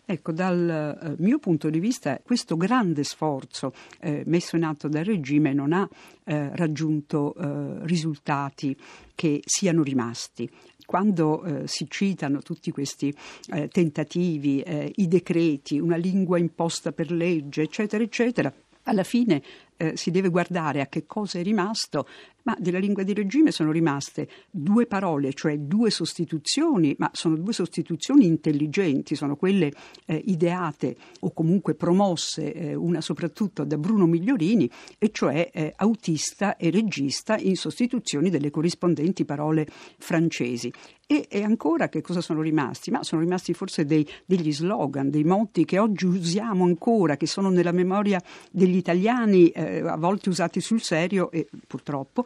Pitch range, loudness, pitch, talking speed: 155-190 Hz, -25 LUFS, 170 Hz, 150 wpm